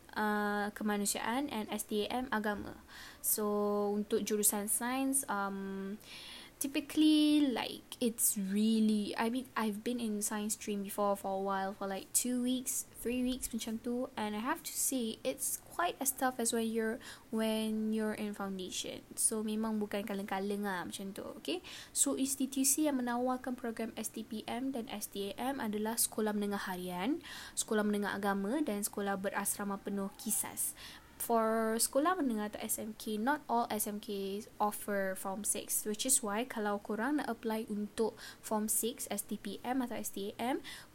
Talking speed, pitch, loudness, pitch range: 150 wpm, 220 Hz, -35 LUFS, 205-250 Hz